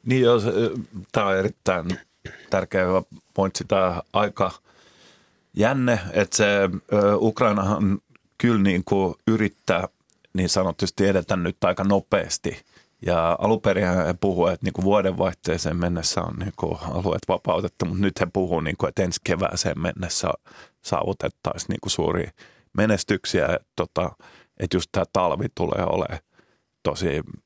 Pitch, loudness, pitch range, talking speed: 95 Hz, -23 LUFS, 90-105 Hz, 135 wpm